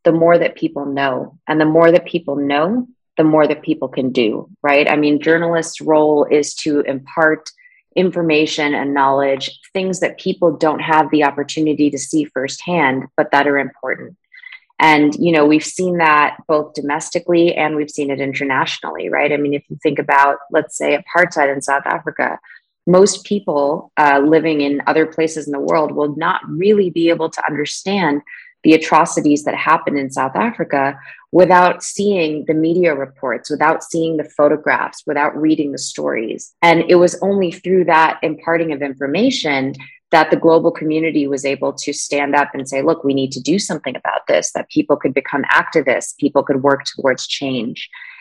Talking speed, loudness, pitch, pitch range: 180 wpm, -16 LUFS, 155 Hz, 140-170 Hz